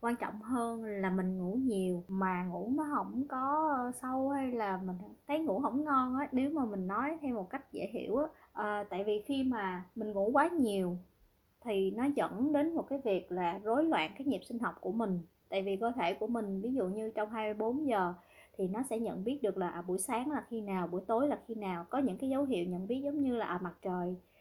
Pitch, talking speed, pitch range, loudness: 225 Hz, 245 wpm, 190-265 Hz, -35 LUFS